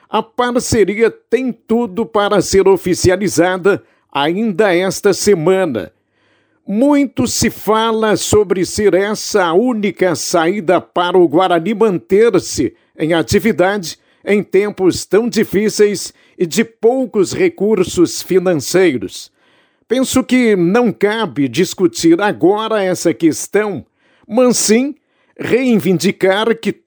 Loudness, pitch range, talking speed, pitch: -14 LUFS, 185-230 Hz, 105 wpm, 205 Hz